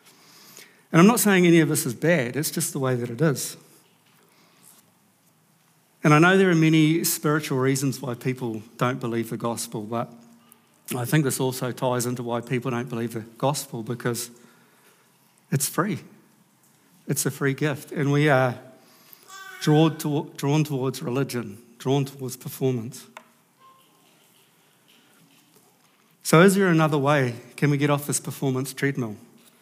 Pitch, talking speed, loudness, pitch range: 135 Hz, 145 wpm, -23 LUFS, 120-155 Hz